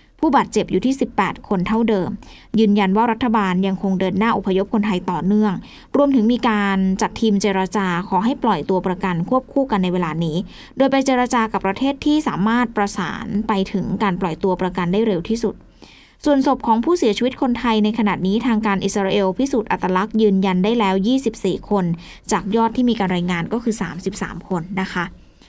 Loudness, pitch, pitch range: -19 LUFS, 210 Hz, 190-230 Hz